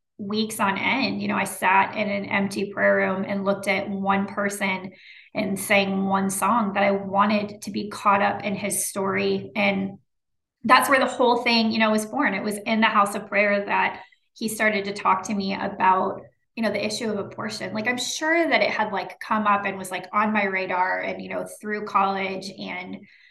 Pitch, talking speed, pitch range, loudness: 205 Hz, 215 wpm, 195-215 Hz, -23 LUFS